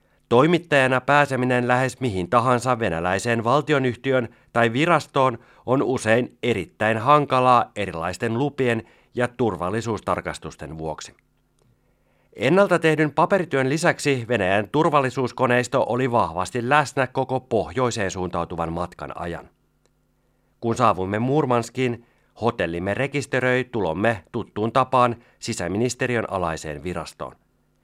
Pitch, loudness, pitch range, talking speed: 120 Hz, -22 LUFS, 100-130 Hz, 95 wpm